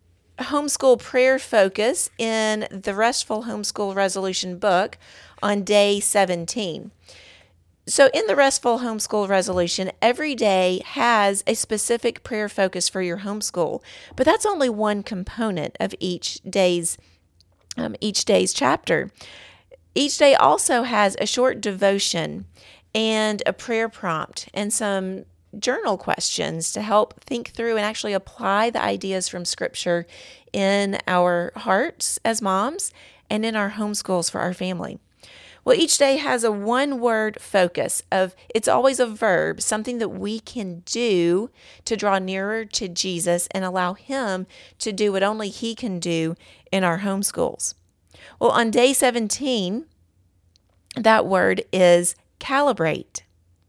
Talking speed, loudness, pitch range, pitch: 135 wpm, -21 LUFS, 185-230 Hz, 205 Hz